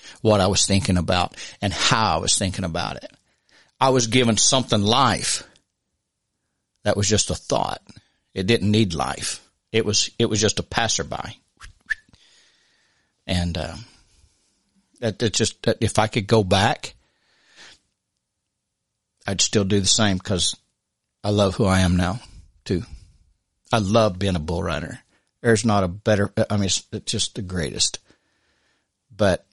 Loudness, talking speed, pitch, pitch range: -21 LUFS, 150 wpm, 100 Hz, 90-110 Hz